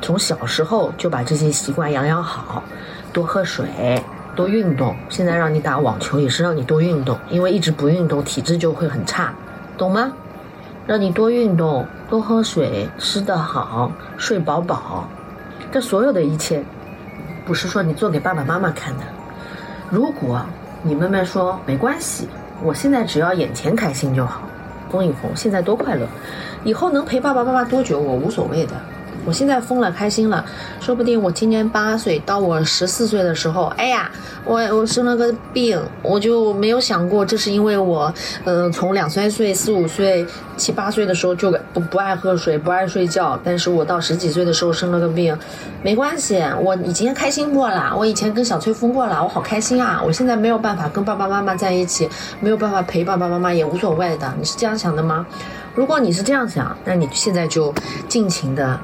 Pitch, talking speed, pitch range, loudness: 185 Hz, 285 characters per minute, 160-220 Hz, -19 LUFS